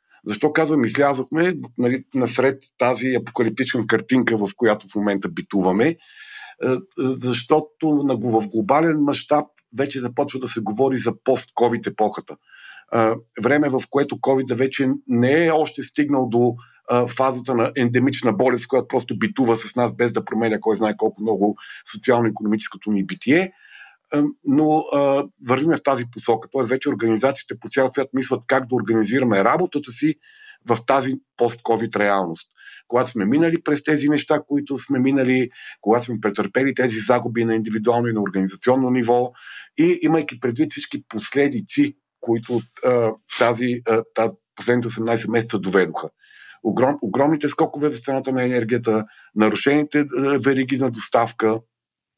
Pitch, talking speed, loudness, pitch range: 125 Hz, 145 wpm, -21 LUFS, 115-140 Hz